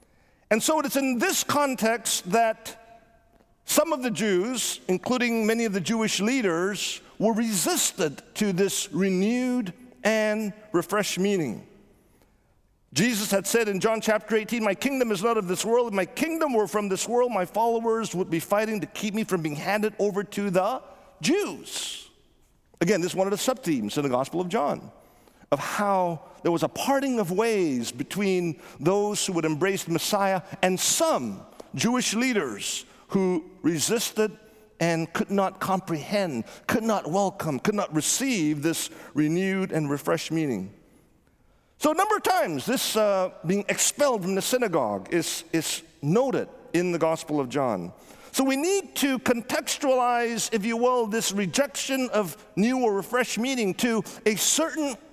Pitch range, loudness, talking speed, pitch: 185-235 Hz, -25 LUFS, 160 wpm, 210 Hz